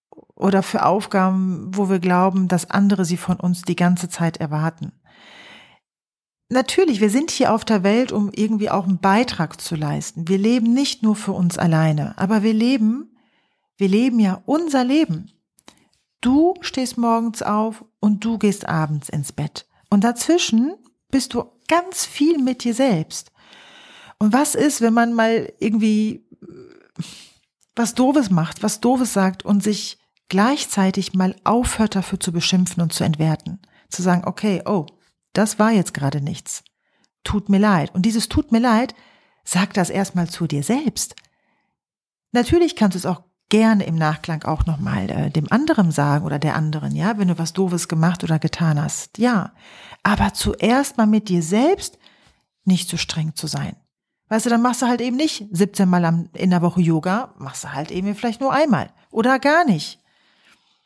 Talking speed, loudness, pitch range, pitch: 170 wpm, -19 LUFS, 175-235 Hz, 200 Hz